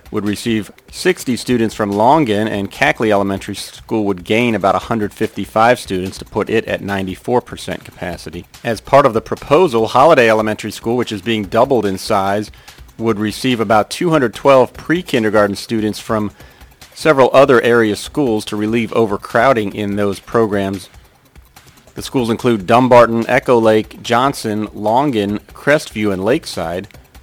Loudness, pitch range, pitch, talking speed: -15 LUFS, 100-115 Hz, 110 Hz, 140 wpm